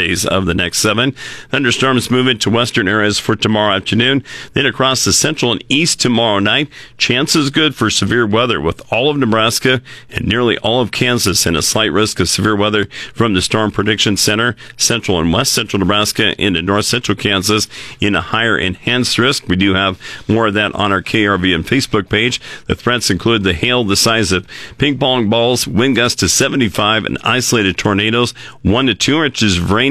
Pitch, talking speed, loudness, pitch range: 110 Hz, 195 wpm, -13 LUFS, 100-120 Hz